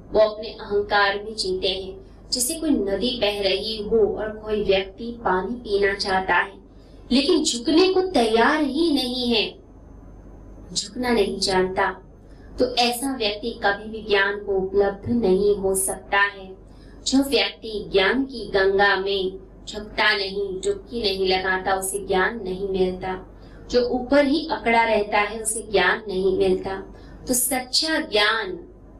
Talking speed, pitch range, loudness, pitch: 145 wpm, 195-235 Hz, -22 LUFS, 205 Hz